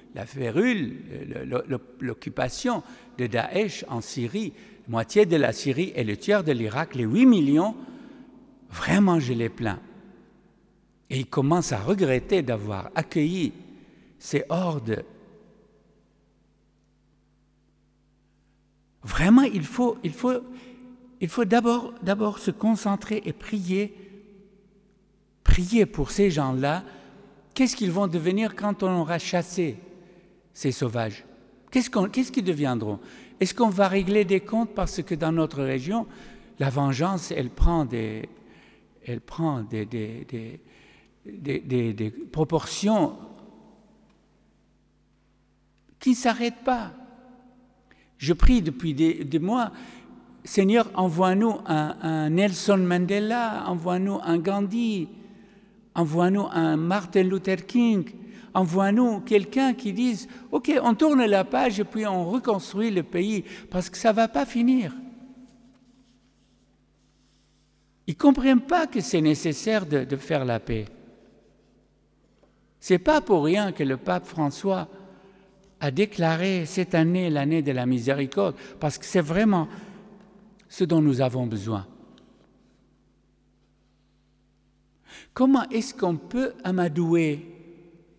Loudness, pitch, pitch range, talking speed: -25 LUFS, 185 Hz, 150-215 Hz, 120 wpm